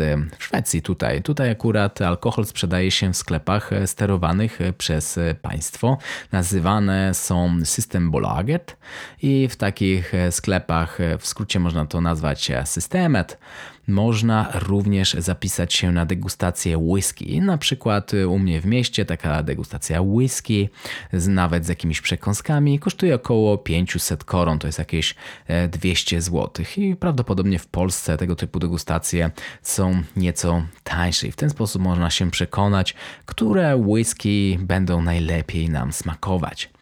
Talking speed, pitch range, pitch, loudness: 130 wpm, 85-105 Hz, 90 Hz, -21 LUFS